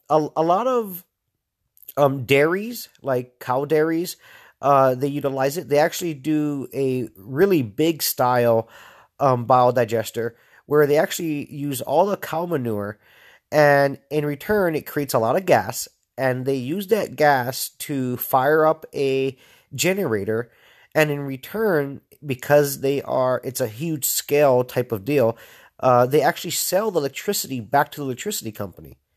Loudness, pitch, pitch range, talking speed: -21 LUFS, 140 Hz, 125-155 Hz, 150 wpm